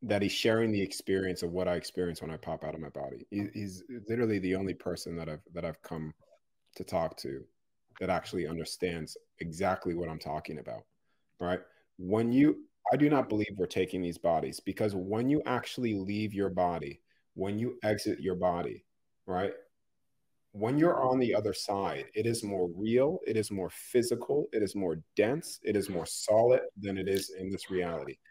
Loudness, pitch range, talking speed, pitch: -32 LUFS, 90-115 Hz, 190 wpm, 100 Hz